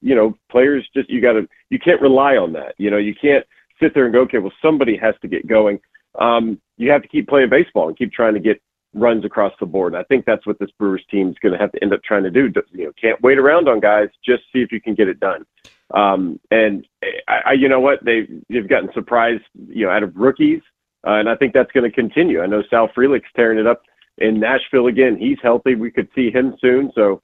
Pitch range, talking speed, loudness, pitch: 105-135 Hz, 255 wpm, -16 LUFS, 120 Hz